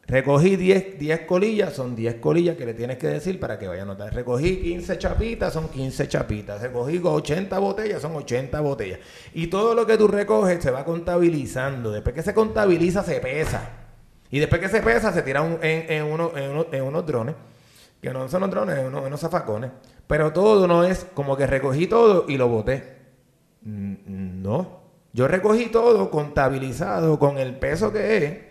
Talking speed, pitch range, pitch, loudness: 185 wpm, 130-185 Hz, 155 Hz, -22 LUFS